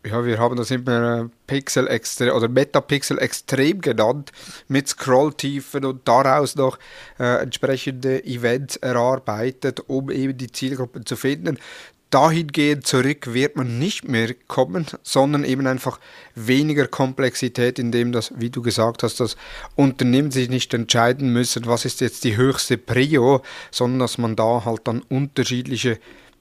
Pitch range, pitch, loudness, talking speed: 120-135 Hz, 130 Hz, -20 LUFS, 140 wpm